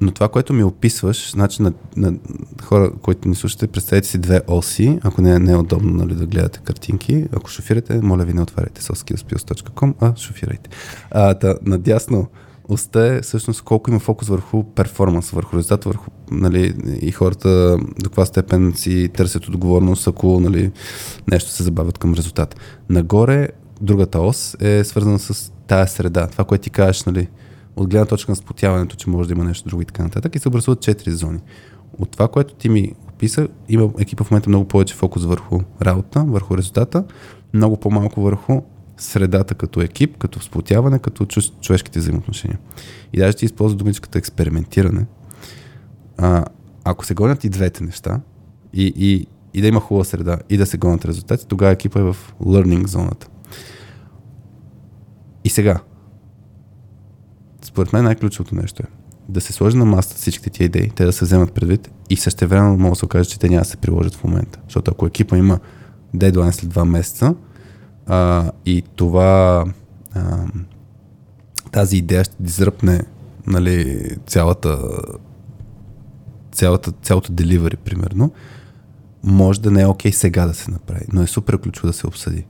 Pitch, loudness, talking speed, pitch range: 100 Hz, -17 LUFS, 165 wpm, 90-110 Hz